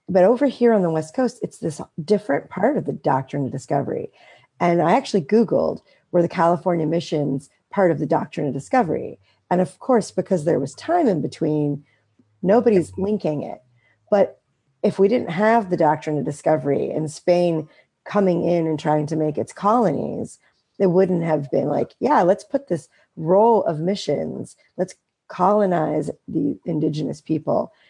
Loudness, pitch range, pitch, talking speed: -21 LUFS, 150-195 Hz, 170 Hz, 170 wpm